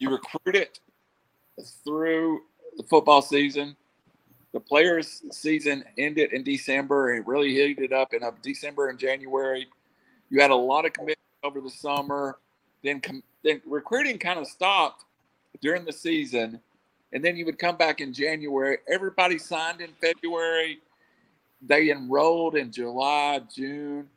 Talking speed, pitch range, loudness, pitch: 140 wpm, 135-160 Hz, -25 LUFS, 145 Hz